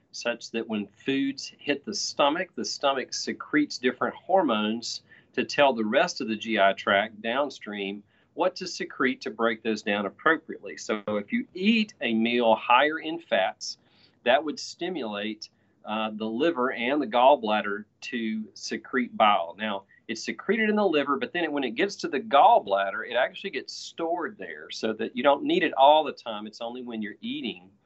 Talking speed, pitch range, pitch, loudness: 180 wpm, 110-145 Hz, 115 Hz, -26 LUFS